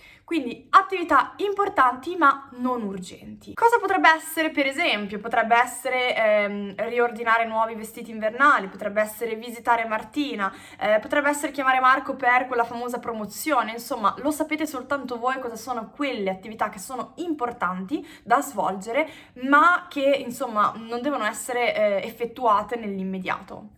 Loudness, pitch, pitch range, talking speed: -23 LUFS, 245 Hz, 220-285 Hz, 135 wpm